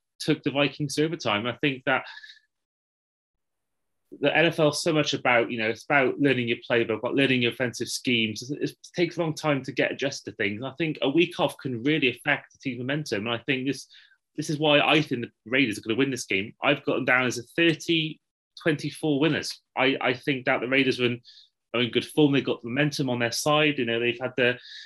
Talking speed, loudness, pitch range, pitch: 230 wpm, -25 LUFS, 120-150 Hz, 135 Hz